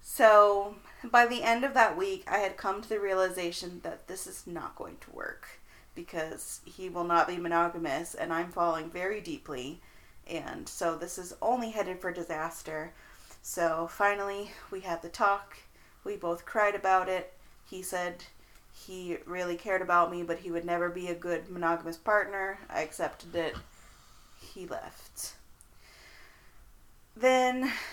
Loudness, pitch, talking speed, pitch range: -31 LUFS, 185 Hz, 155 wpm, 170-205 Hz